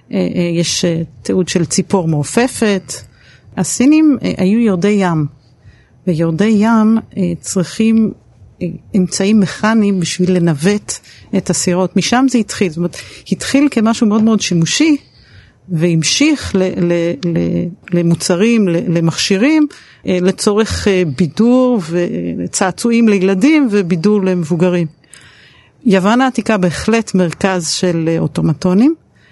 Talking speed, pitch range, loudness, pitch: 95 wpm, 170-220 Hz, -13 LUFS, 185 Hz